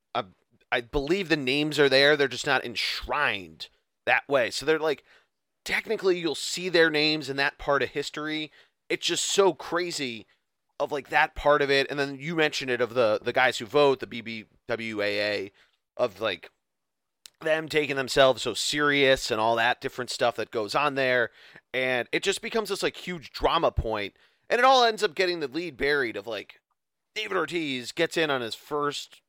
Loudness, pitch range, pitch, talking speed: -26 LUFS, 130-165 Hz, 145 Hz, 185 wpm